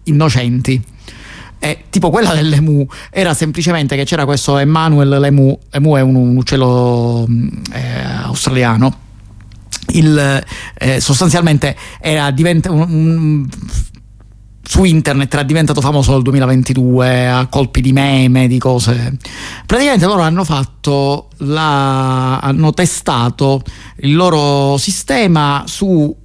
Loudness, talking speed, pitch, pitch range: -12 LUFS, 110 wpm, 140 Hz, 125-155 Hz